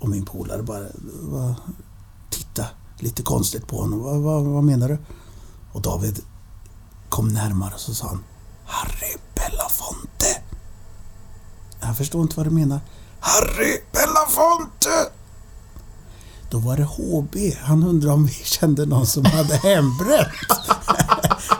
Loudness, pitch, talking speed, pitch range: -21 LUFS, 110 Hz, 130 wpm, 95-145 Hz